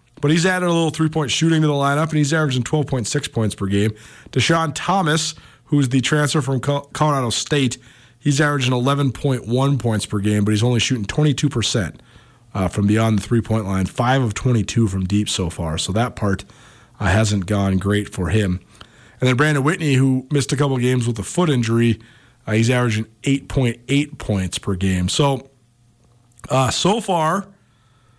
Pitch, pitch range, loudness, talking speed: 125 Hz, 110-145 Hz, -19 LUFS, 180 wpm